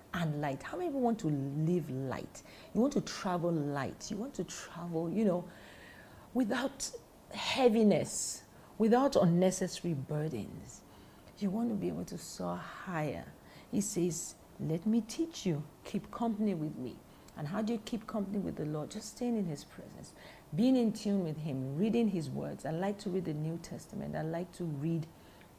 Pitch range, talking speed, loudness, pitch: 160-220 Hz, 175 wpm, -35 LUFS, 185 Hz